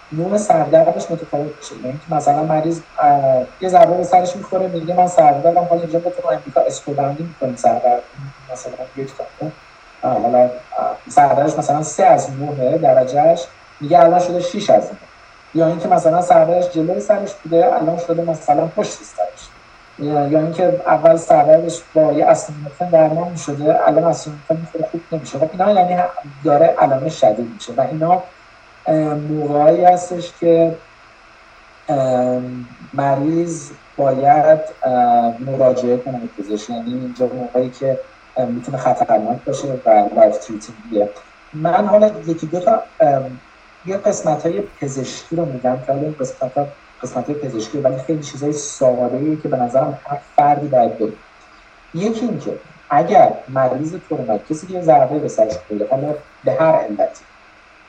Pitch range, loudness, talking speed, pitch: 130-170 Hz, -16 LUFS, 130 wpm, 155 Hz